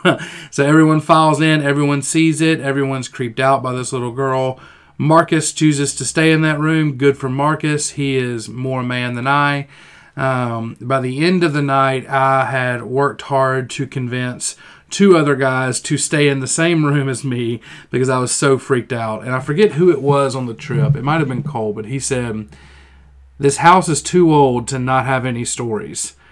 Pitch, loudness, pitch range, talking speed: 135 Hz, -16 LUFS, 125-150 Hz, 200 wpm